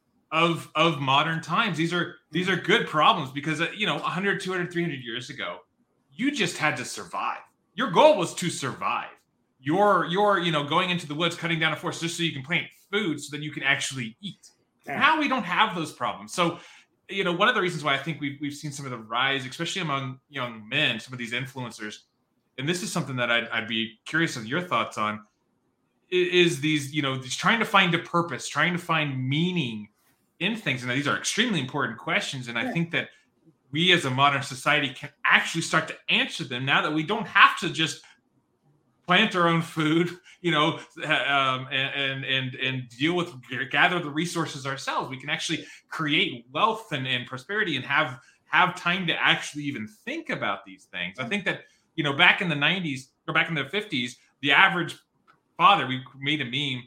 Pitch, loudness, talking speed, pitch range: 155 Hz, -25 LUFS, 205 wpm, 130-175 Hz